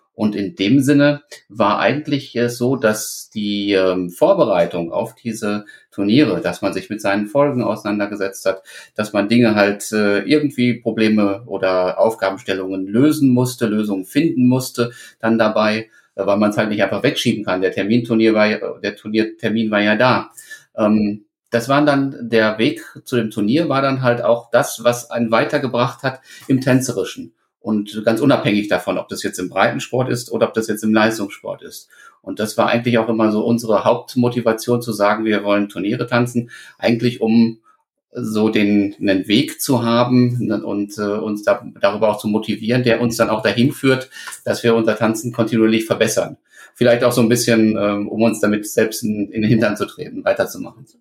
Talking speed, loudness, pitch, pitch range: 180 wpm, -17 LUFS, 110 Hz, 105-120 Hz